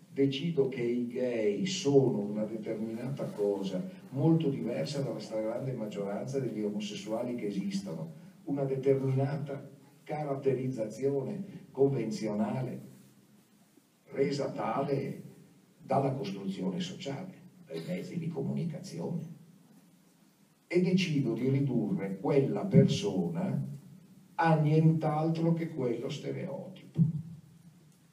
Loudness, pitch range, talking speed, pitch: -32 LUFS, 125-175 Hz, 85 wpm, 140 Hz